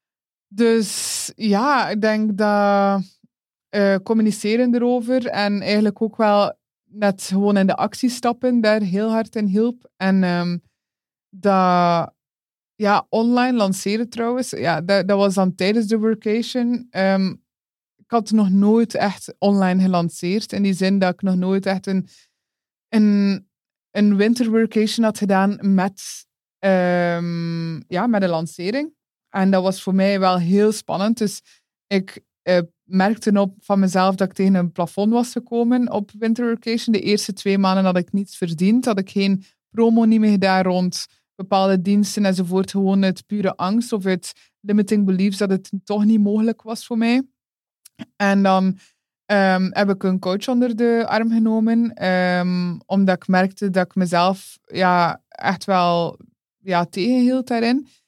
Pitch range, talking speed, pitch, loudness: 190-225 Hz, 155 wpm, 200 Hz, -19 LUFS